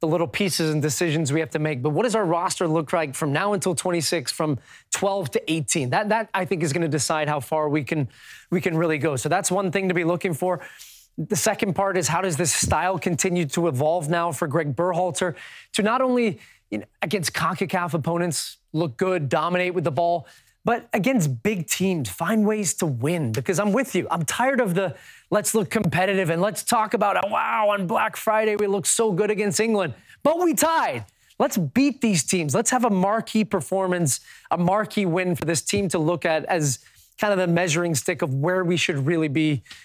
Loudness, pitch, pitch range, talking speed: -23 LUFS, 180 Hz, 165-205 Hz, 215 wpm